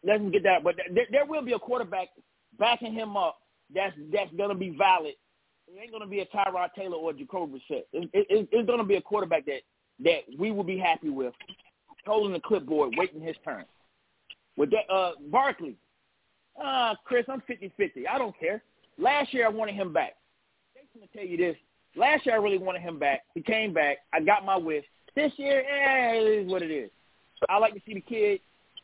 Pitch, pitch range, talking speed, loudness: 215 Hz, 185-270 Hz, 205 wpm, -28 LUFS